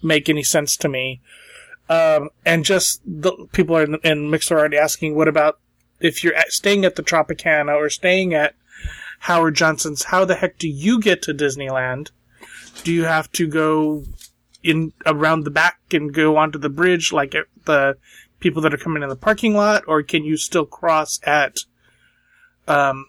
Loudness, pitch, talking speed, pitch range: -18 LUFS, 160 Hz, 175 wpm, 150-180 Hz